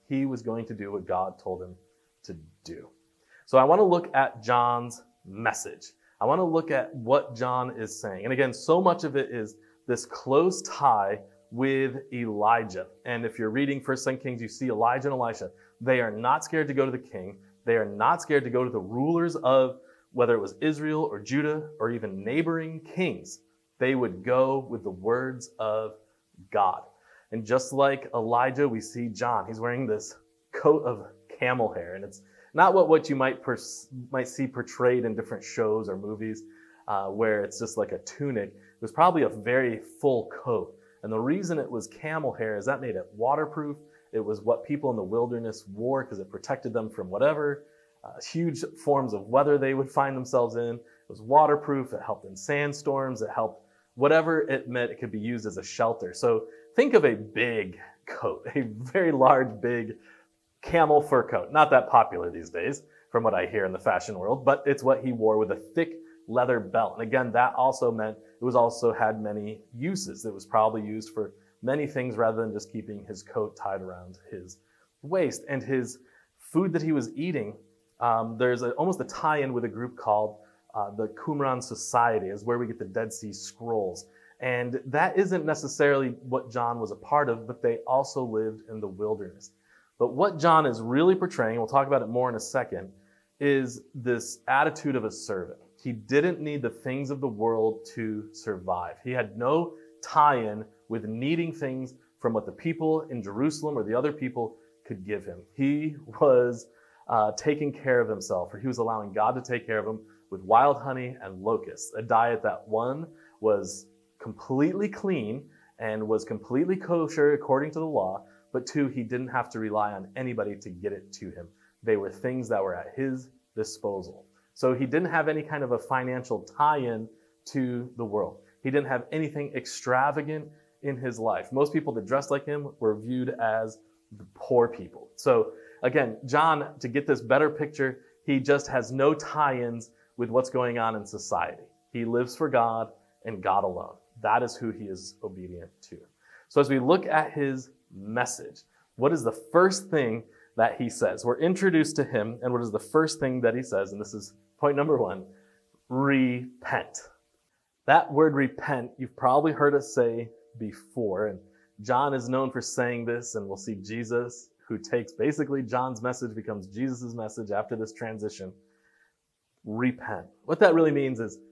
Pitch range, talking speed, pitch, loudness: 110-145 Hz, 190 wpm, 125 Hz, -27 LUFS